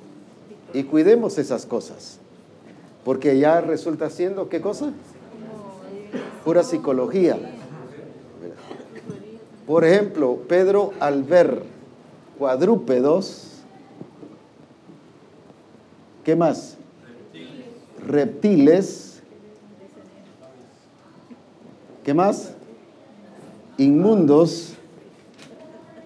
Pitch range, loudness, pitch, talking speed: 155-205 Hz, -20 LUFS, 170 Hz, 55 wpm